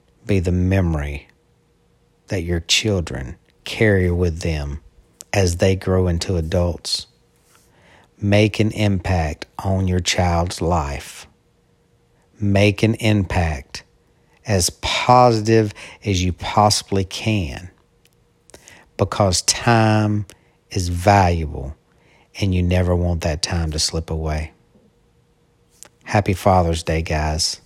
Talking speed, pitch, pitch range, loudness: 100 wpm, 90 Hz, 85-100 Hz, -19 LUFS